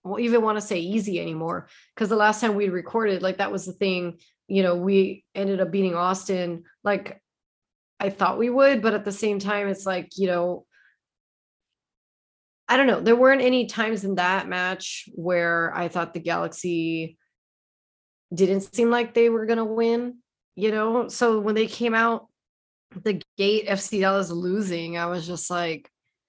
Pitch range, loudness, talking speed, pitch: 180-220 Hz, -23 LUFS, 180 wpm, 195 Hz